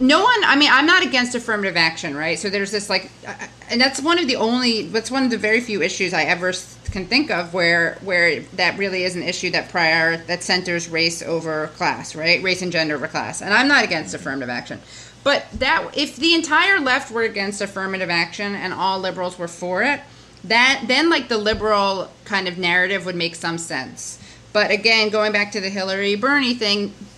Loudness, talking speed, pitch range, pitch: -18 LUFS, 210 wpm, 175-235 Hz, 195 Hz